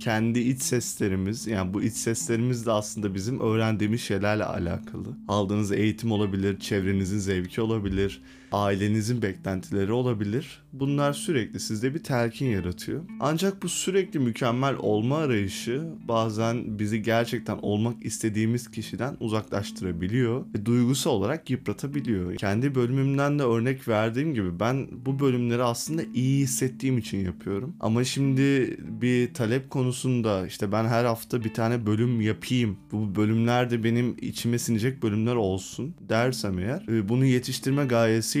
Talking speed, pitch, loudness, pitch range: 135 wpm, 115 Hz, -26 LUFS, 105-125 Hz